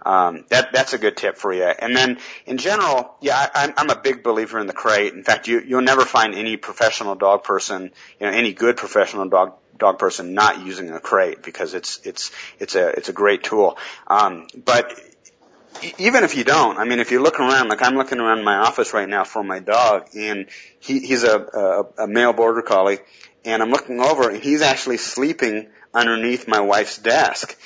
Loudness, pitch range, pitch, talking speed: -18 LUFS, 110-140 Hz, 120 Hz, 210 wpm